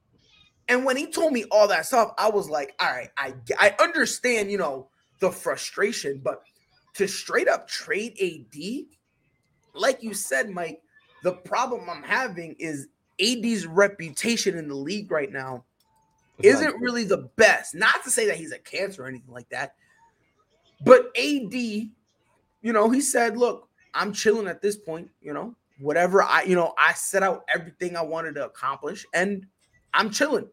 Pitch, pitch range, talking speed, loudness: 200 Hz, 165-240 Hz, 170 wpm, -24 LUFS